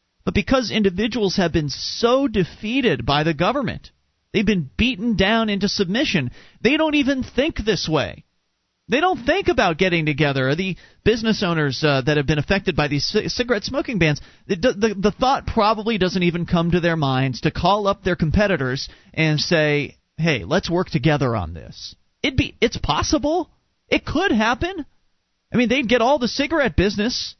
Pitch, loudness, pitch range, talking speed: 195 Hz, -20 LUFS, 155-235 Hz, 175 wpm